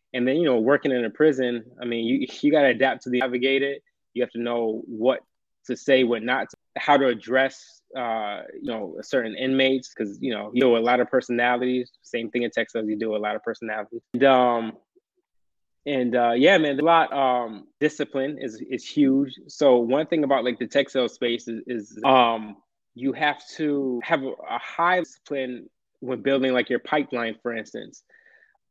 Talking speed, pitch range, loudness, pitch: 200 wpm, 120-140 Hz, -23 LUFS, 125 Hz